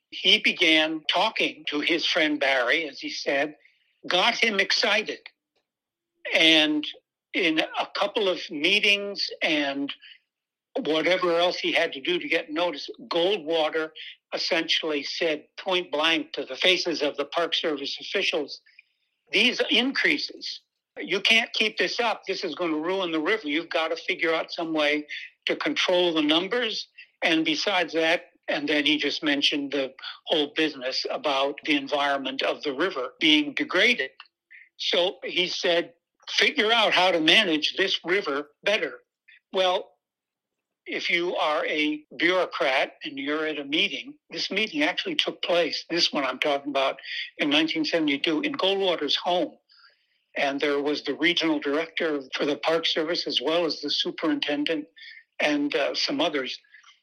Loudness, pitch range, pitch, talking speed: -24 LUFS, 150-220 Hz, 170 Hz, 150 wpm